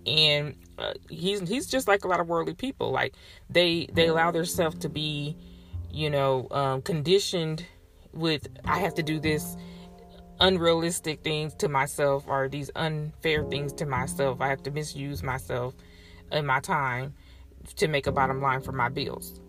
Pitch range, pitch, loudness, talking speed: 130-165 Hz, 145 Hz, -27 LUFS, 165 wpm